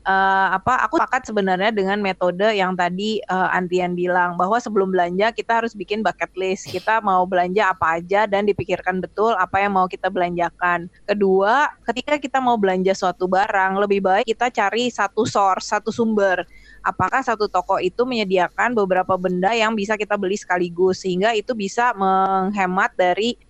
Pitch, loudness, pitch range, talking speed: 195 Hz, -20 LUFS, 185-220 Hz, 165 wpm